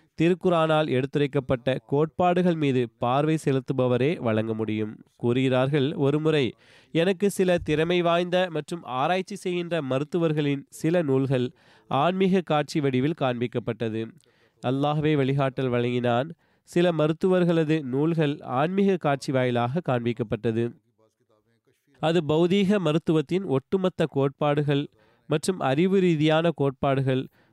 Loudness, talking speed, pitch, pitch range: -25 LUFS, 95 wpm, 145 Hz, 125-165 Hz